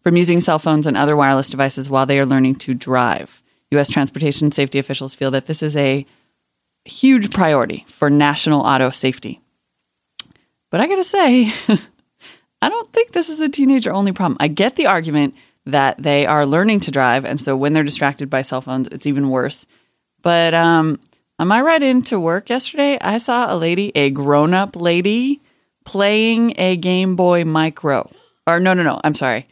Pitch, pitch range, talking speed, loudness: 155 Hz, 140-200 Hz, 180 wpm, -16 LUFS